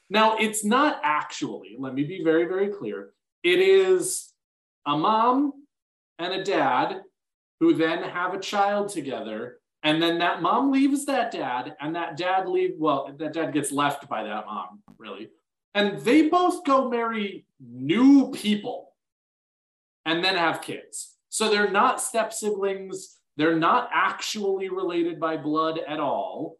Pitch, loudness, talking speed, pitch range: 200 Hz, -24 LUFS, 150 wpm, 160-270 Hz